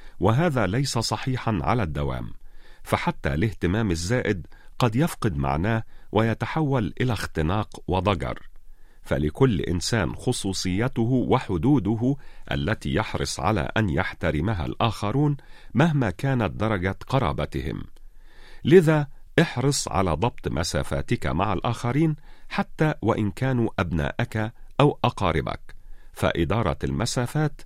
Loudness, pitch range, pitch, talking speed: -25 LUFS, 90-130 Hz, 115 Hz, 95 wpm